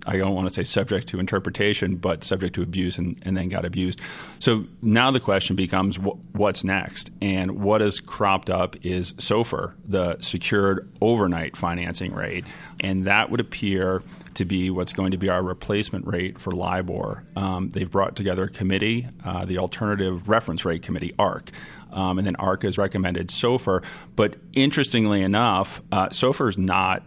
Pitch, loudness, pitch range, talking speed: 95 Hz, -24 LUFS, 90-100 Hz, 175 wpm